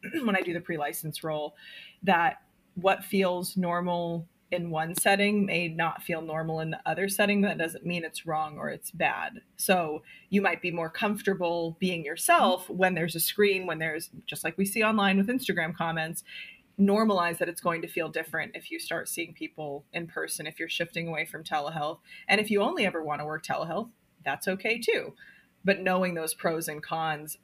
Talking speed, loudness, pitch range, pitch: 195 wpm, -29 LUFS, 160-195 Hz, 175 Hz